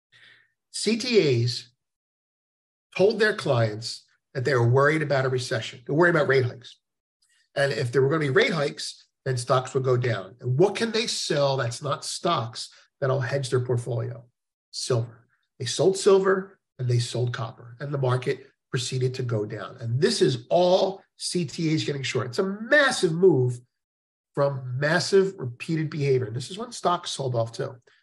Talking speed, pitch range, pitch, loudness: 170 wpm, 125-175 Hz, 135 Hz, -25 LUFS